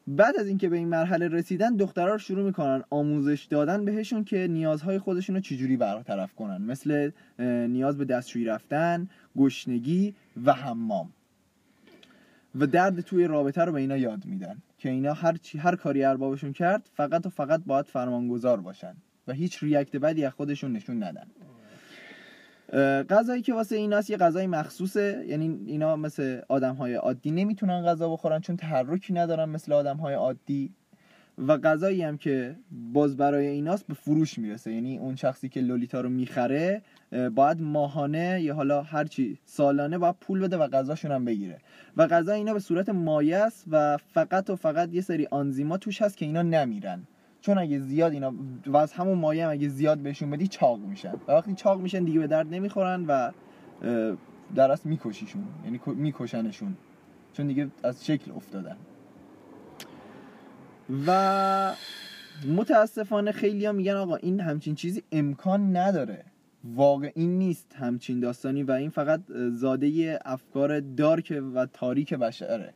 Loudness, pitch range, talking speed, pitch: -27 LUFS, 140-190 Hz, 155 wpm, 155 Hz